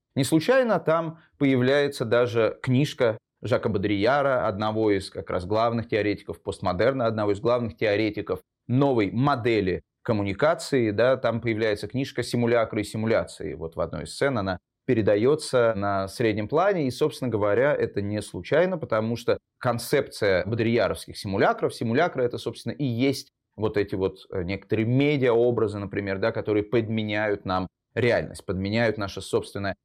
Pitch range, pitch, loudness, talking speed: 105-130 Hz, 115 Hz, -25 LUFS, 140 wpm